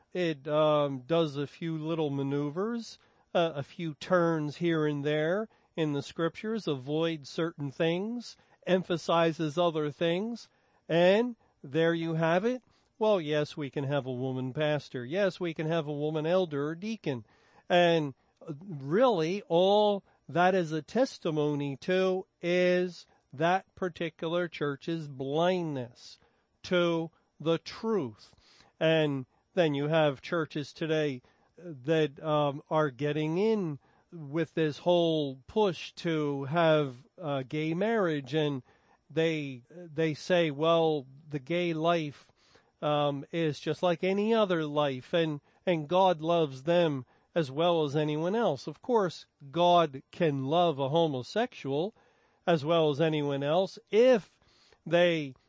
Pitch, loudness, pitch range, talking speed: 165 Hz, -30 LUFS, 150-175 Hz, 130 wpm